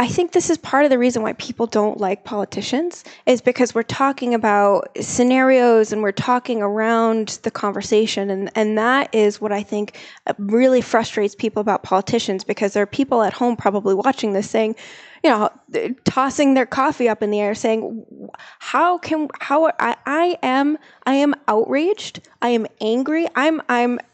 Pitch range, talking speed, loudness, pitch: 210-265 Hz, 175 wpm, -19 LUFS, 230 Hz